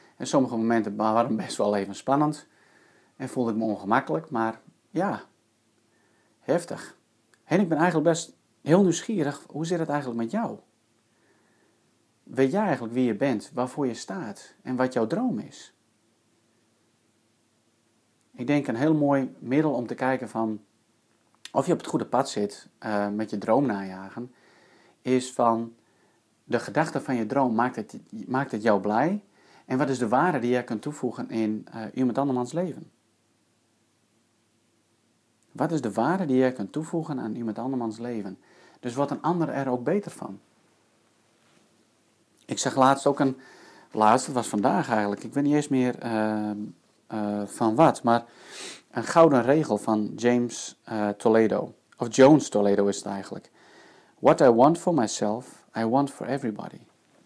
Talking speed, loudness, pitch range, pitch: 160 wpm, -25 LUFS, 110-135 Hz, 115 Hz